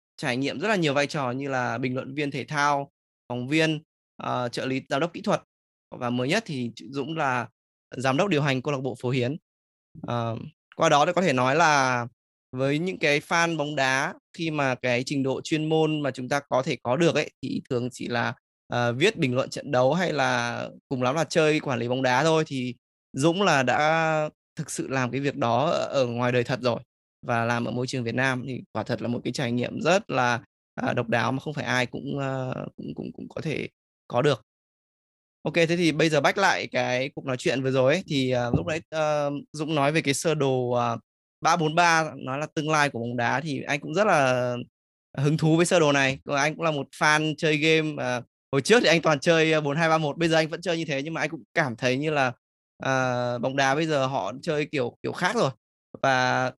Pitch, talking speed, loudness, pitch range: 135 Hz, 240 wpm, -25 LUFS, 125-155 Hz